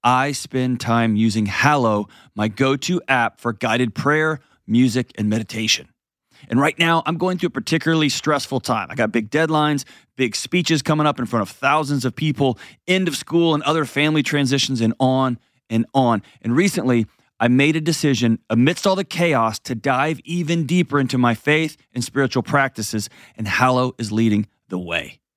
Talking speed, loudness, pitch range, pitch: 180 wpm, -19 LUFS, 115-155 Hz, 130 Hz